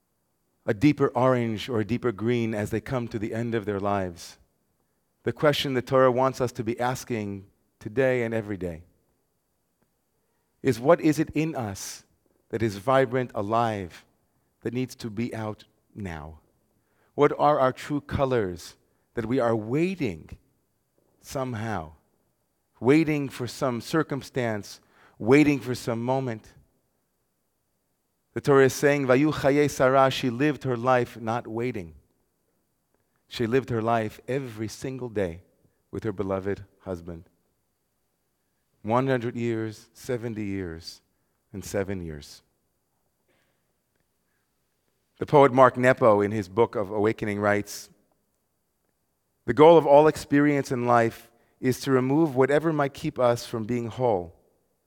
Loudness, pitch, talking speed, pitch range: -25 LUFS, 115 Hz, 130 wpm, 105-130 Hz